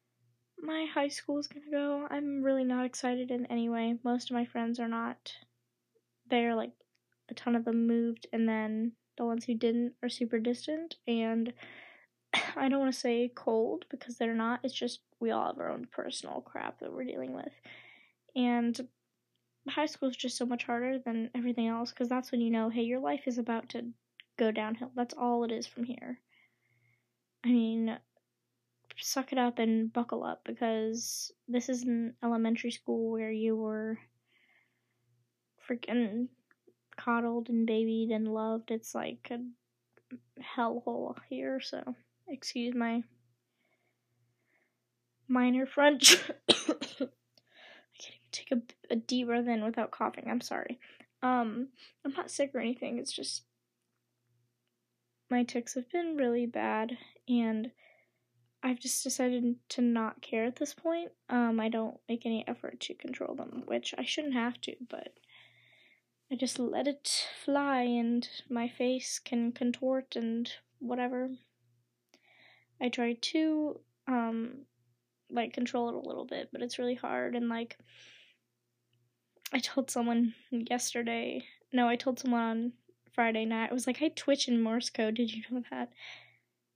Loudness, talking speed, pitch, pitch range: -33 LUFS, 155 wpm, 240 Hz, 225-255 Hz